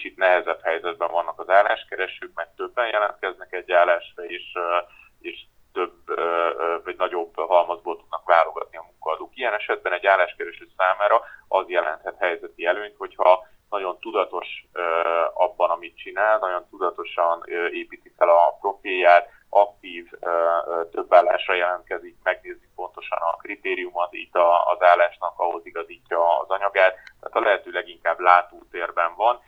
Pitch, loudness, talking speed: 90 Hz, -22 LUFS, 130 wpm